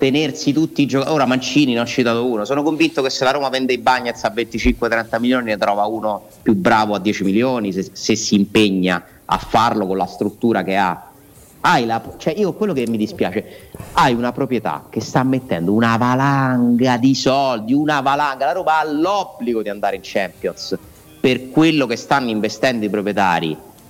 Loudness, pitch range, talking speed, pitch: -18 LUFS, 105-135 Hz, 190 wpm, 120 Hz